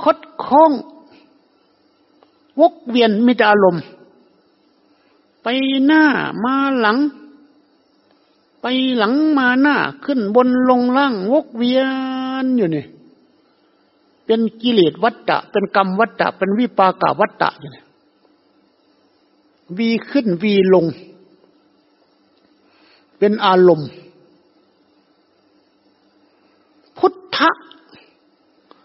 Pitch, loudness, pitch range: 255 Hz, -16 LUFS, 205-300 Hz